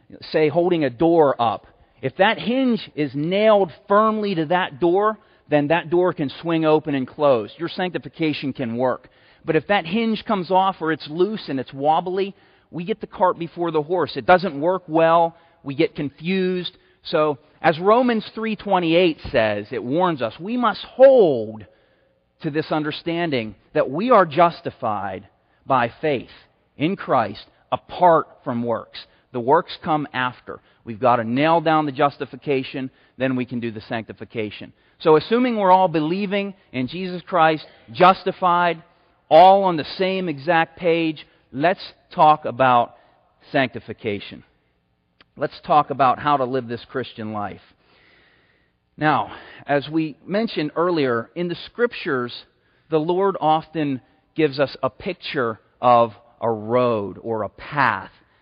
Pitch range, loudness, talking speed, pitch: 130-180 Hz, -20 LUFS, 145 wpm, 160 Hz